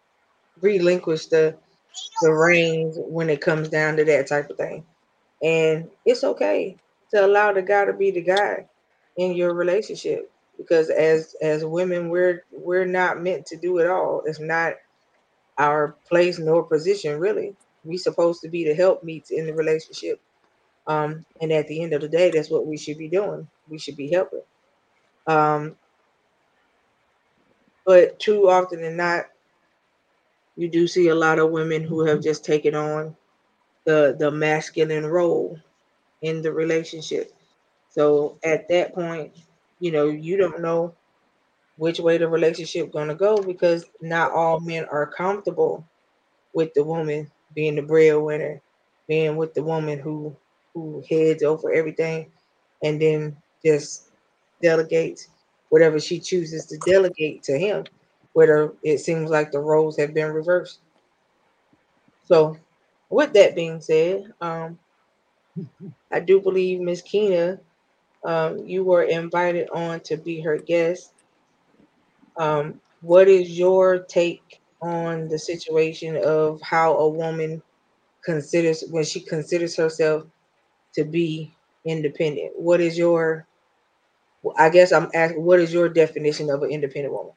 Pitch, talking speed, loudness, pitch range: 165 Hz, 145 wpm, -21 LUFS, 155-180 Hz